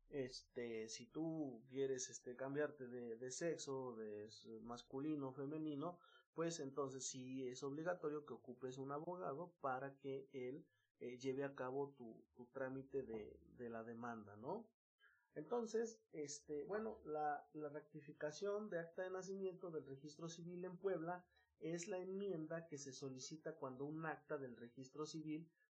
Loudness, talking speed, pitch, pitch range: -49 LUFS, 150 wpm, 145 Hz, 130-165 Hz